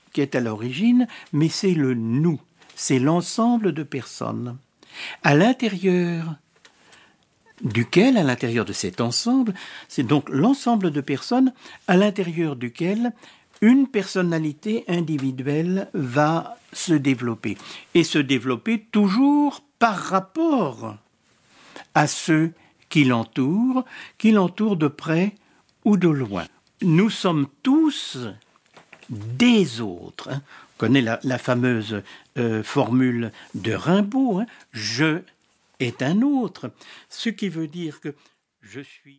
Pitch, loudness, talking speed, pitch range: 160 Hz, -22 LUFS, 115 wpm, 130-210 Hz